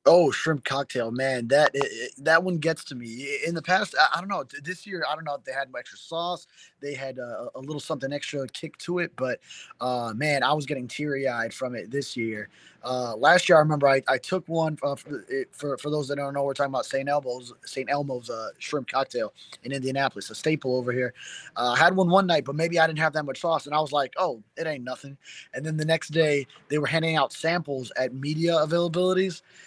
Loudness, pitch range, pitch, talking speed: -26 LUFS, 135-165 Hz, 145 Hz, 240 wpm